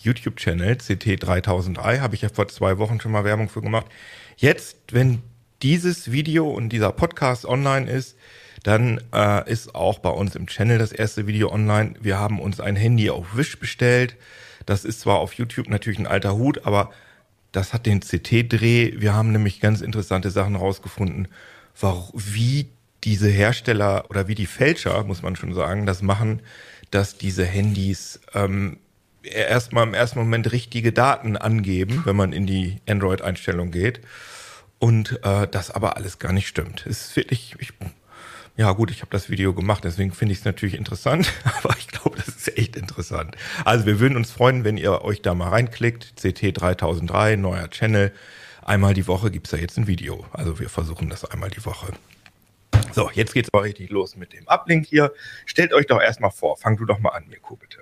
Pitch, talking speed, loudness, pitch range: 105 Hz, 185 wpm, -22 LUFS, 95-115 Hz